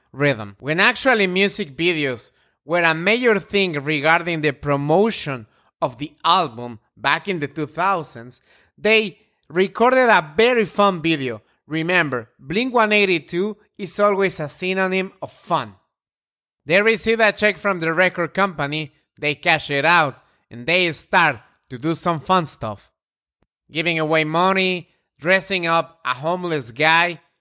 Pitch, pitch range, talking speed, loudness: 170 Hz, 150-195 Hz, 135 wpm, -19 LUFS